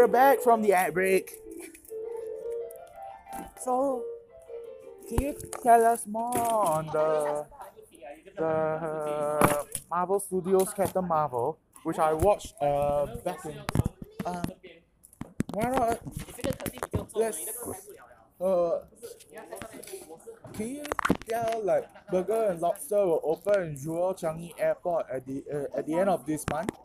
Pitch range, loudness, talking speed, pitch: 155-245 Hz, -28 LUFS, 105 wpm, 190 Hz